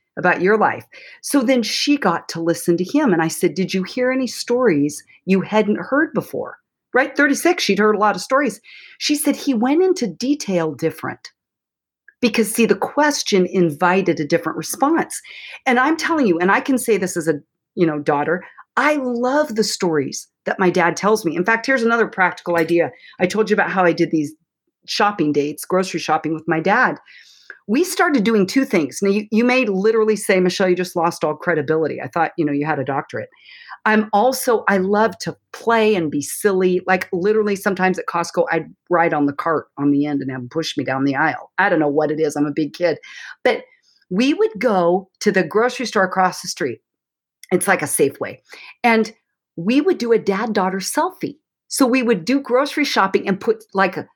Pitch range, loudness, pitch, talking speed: 170-250 Hz, -18 LUFS, 195 Hz, 210 wpm